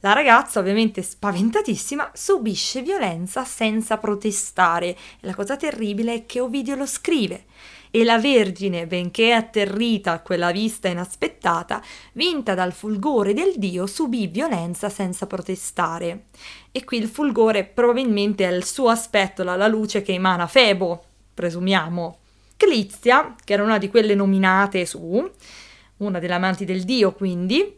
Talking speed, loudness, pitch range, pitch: 140 wpm, -21 LUFS, 185-230 Hz, 205 Hz